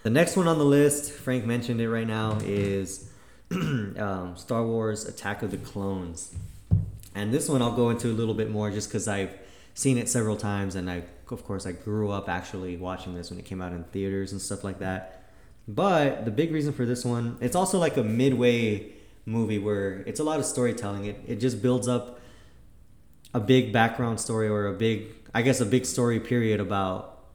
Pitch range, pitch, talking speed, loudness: 100-120 Hz, 110 Hz, 205 wpm, -27 LUFS